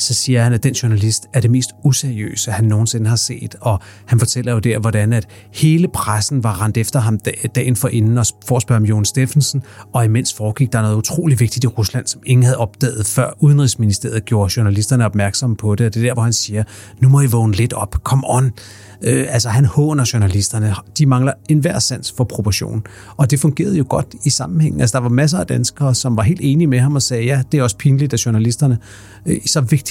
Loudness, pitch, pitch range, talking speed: -16 LUFS, 120 Hz, 110-130 Hz, 230 wpm